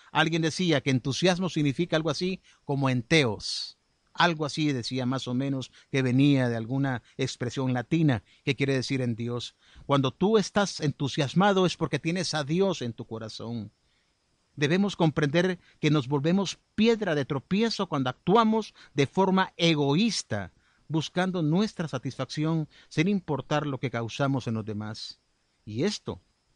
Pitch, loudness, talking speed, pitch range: 150 Hz, -27 LUFS, 145 wpm, 130-175 Hz